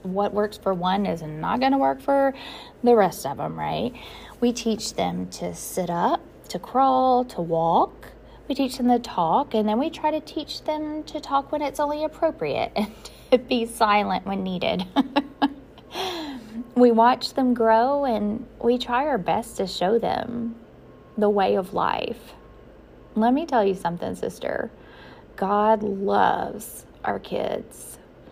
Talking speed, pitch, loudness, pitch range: 160 wpm, 235 Hz, -24 LUFS, 200-275 Hz